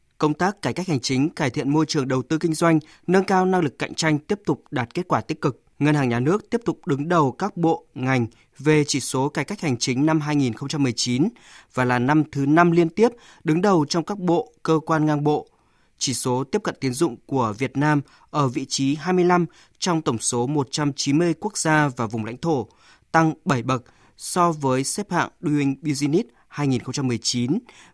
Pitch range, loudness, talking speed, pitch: 135-170 Hz, -22 LUFS, 205 wpm, 150 Hz